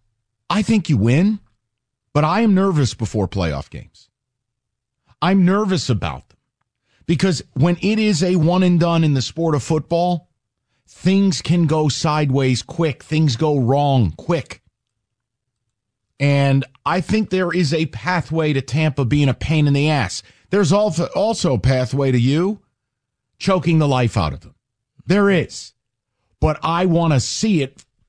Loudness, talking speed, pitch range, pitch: -18 LUFS, 155 wpm, 115-170 Hz, 140 Hz